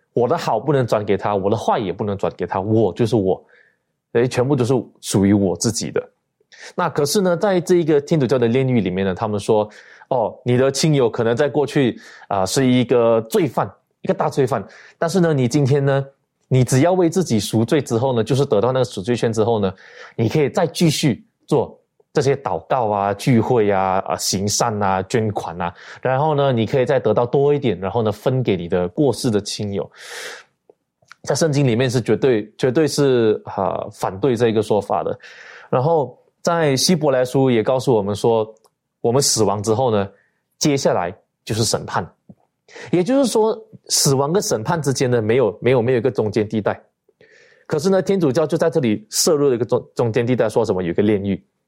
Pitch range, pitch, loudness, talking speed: 110-150 Hz, 130 Hz, -19 LUFS, 290 characters per minute